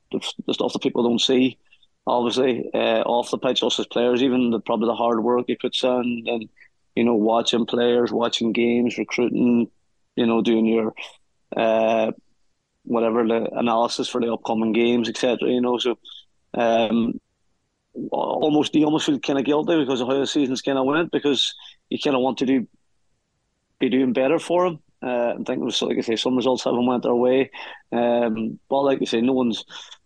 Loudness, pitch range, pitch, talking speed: -21 LUFS, 115-130 Hz, 120 Hz, 190 wpm